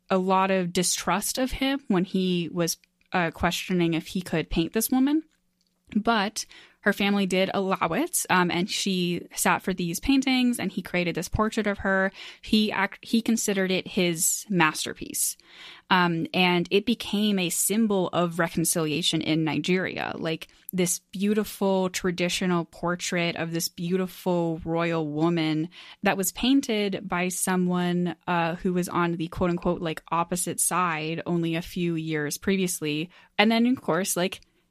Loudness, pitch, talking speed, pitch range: -25 LUFS, 180 Hz, 155 wpm, 170-200 Hz